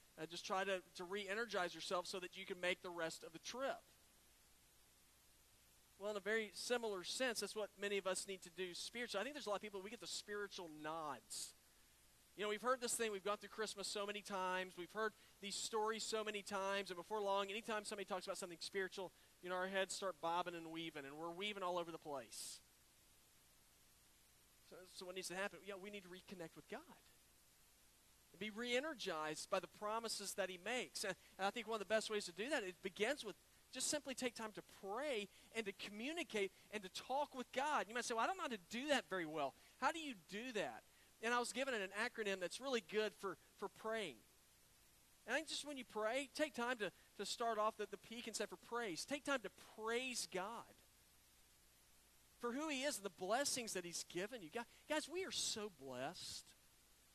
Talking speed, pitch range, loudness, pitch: 225 wpm, 180-230 Hz, -45 LUFS, 200 Hz